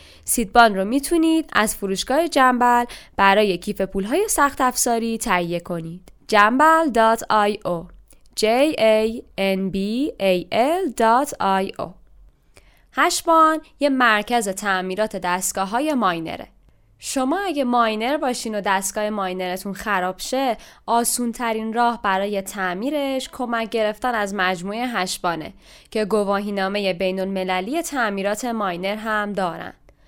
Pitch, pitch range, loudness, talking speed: 215 Hz, 195-250 Hz, -20 LUFS, 110 wpm